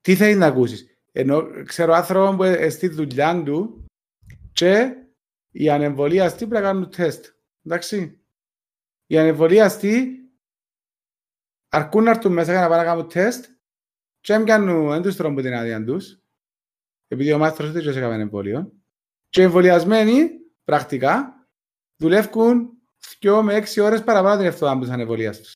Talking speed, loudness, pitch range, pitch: 110 wpm, -19 LUFS, 150-215 Hz, 175 Hz